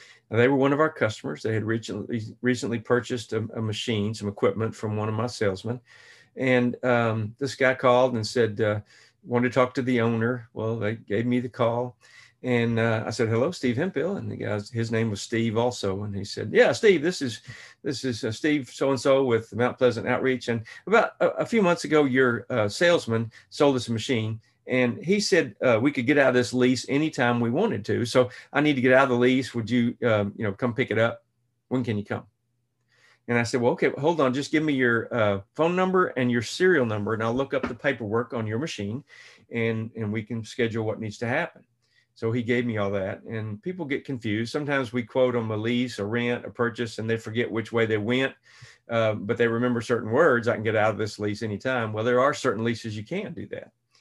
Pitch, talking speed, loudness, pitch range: 120 Hz, 230 wpm, -25 LUFS, 110-130 Hz